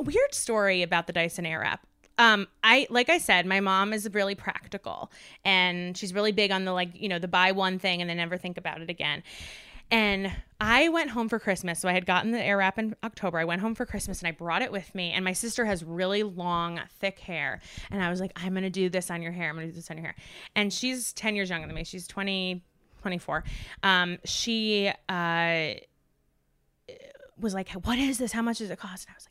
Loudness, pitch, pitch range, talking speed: -27 LUFS, 190 Hz, 175-215 Hz, 235 wpm